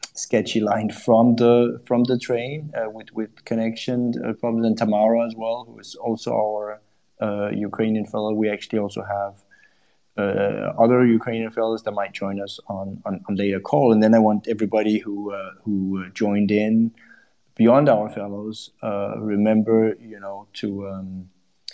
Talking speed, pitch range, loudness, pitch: 165 wpm, 100-115 Hz, -22 LUFS, 110 Hz